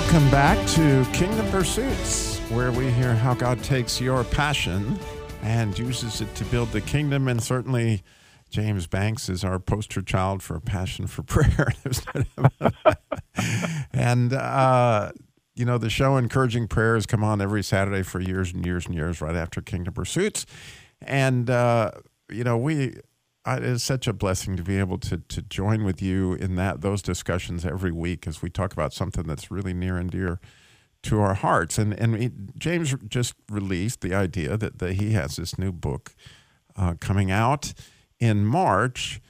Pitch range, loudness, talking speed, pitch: 95-125 Hz, -24 LUFS, 170 wpm, 105 Hz